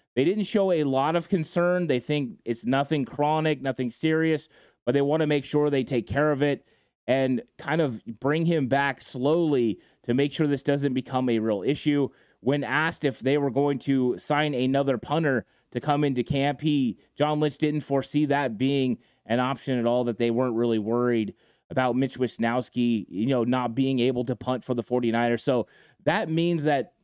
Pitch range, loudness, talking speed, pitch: 125-150 Hz, -25 LUFS, 195 wpm, 135 Hz